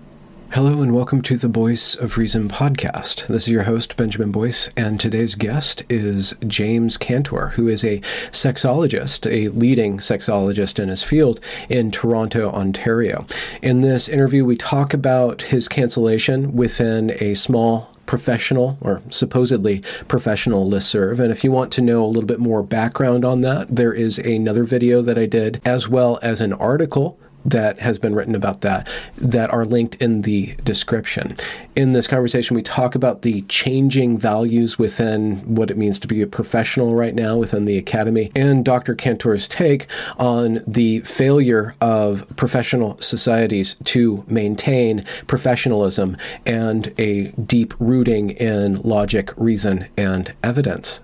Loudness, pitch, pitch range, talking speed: -18 LUFS, 115 Hz, 110-125 Hz, 155 wpm